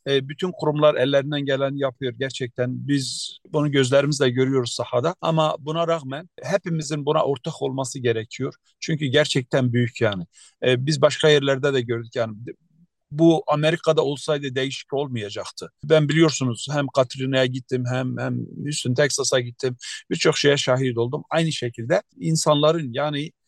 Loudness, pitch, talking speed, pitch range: -22 LUFS, 140 Hz, 135 wpm, 130-155 Hz